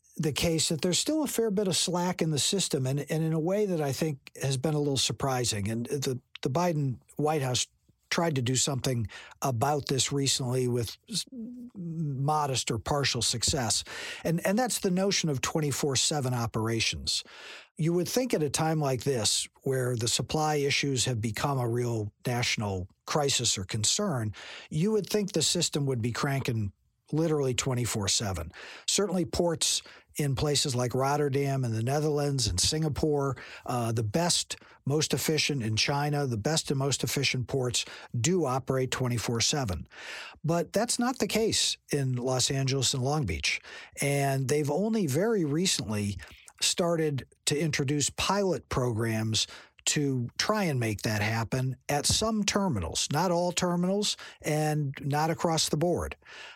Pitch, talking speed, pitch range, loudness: 145 Hz, 155 wpm, 125-165 Hz, -28 LUFS